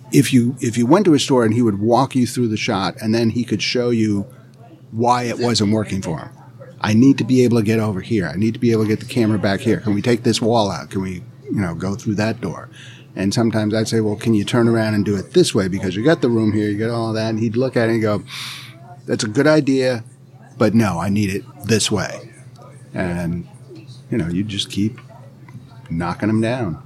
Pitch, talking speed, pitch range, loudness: 115 Hz, 255 wpm, 105-130 Hz, -18 LUFS